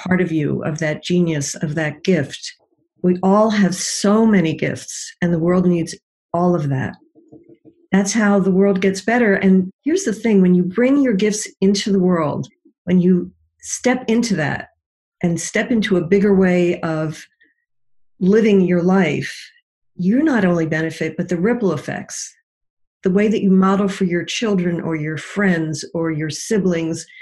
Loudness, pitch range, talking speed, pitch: -18 LUFS, 165-205 Hz, 170 wpm, 185 Hz